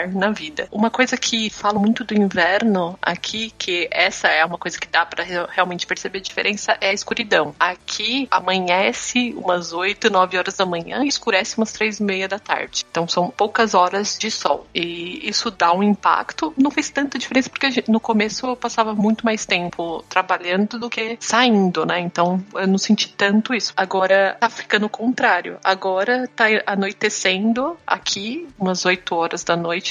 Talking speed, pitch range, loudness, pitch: 185 wpm, 185-230 Hz, -19 LUFS, 205 Hz